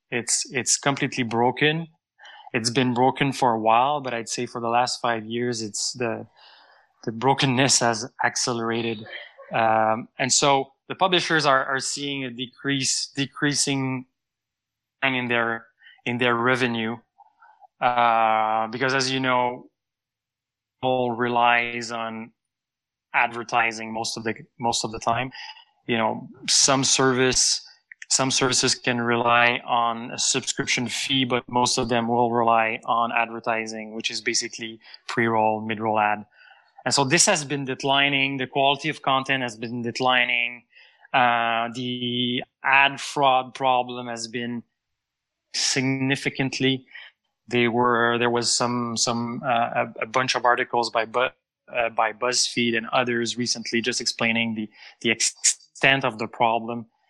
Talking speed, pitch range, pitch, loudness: 135 wpm, 115-130 Hz, 120 Hz, -22 LUFS